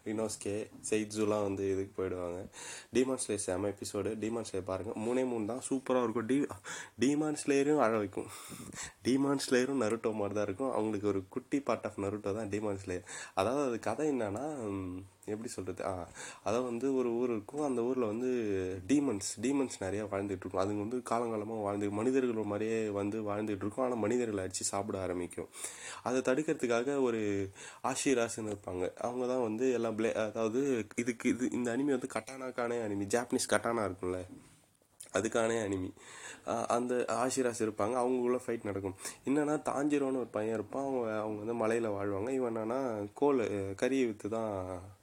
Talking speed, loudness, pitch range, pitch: 150 wpm, -34 LUFS, 100-125 Hz, 110 Hz